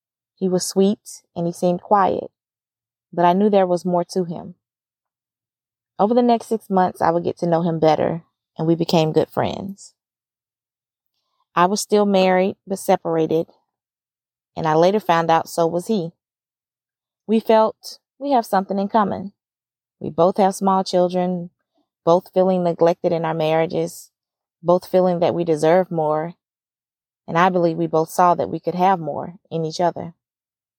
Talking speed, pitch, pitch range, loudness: 165 wpm, 170 Hz, 155-190 Hz, -19 LUFS